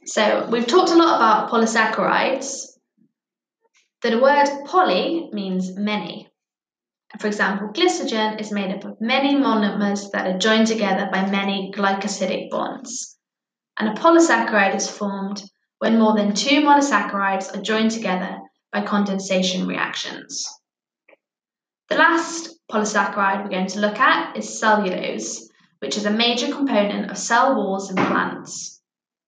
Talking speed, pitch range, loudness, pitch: 135 wpm, 195-265 Hz, -20 LUFS, 210 Hz